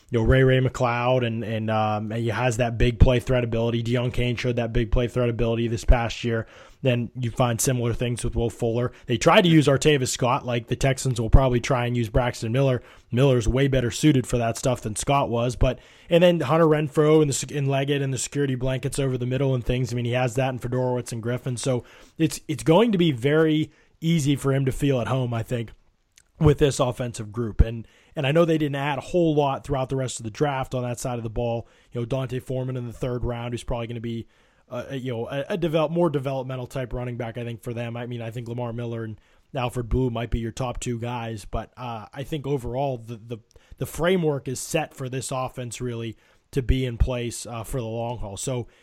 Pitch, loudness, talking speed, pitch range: 125 Hz, -24 LUFS, 245 wpm, 120-135 Hz